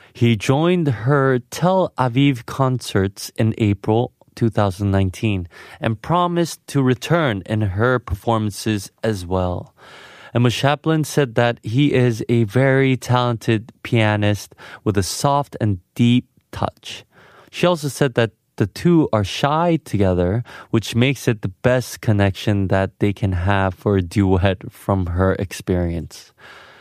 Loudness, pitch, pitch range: -19 LUFS, 115 Hz, 100-135 Hz